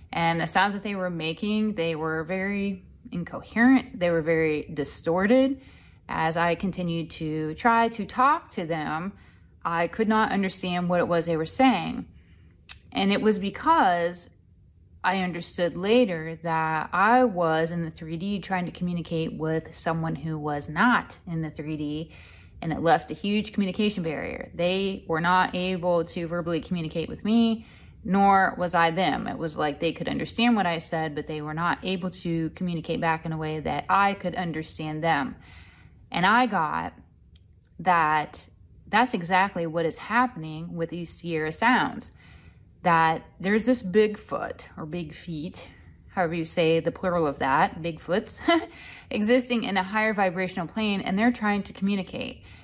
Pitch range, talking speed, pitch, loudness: 160-200 Hz, 160 wpm, 170 Hz, -26 LUFS